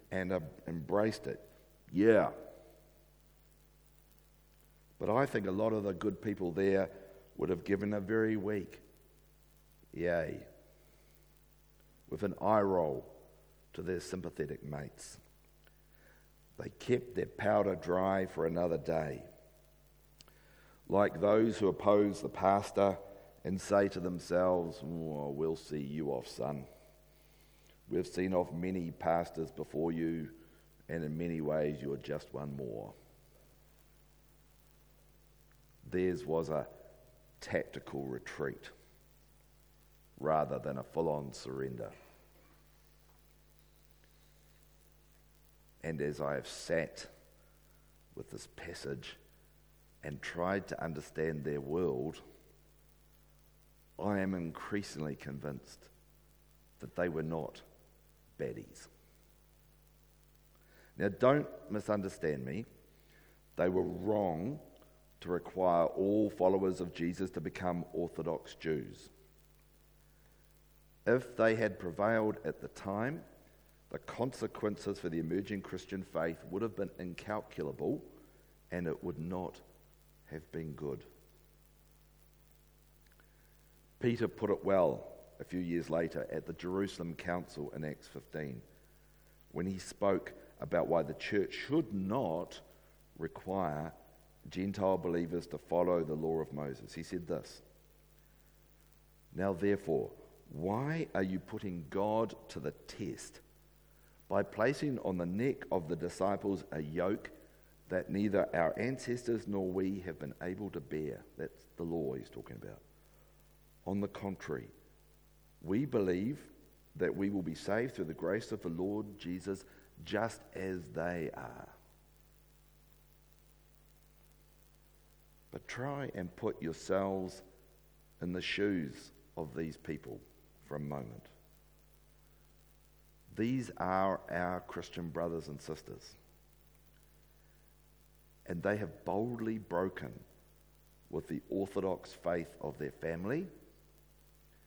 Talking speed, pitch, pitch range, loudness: 110 wpm, 90 Hz, 80-100 Hz, -37 LUFS